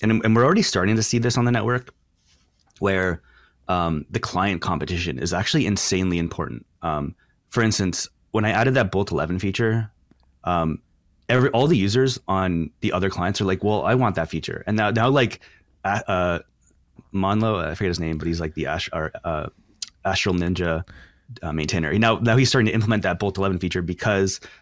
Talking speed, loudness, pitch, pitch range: 190 wpm, -22 LUFS, 95 Hz, 85-110 Hz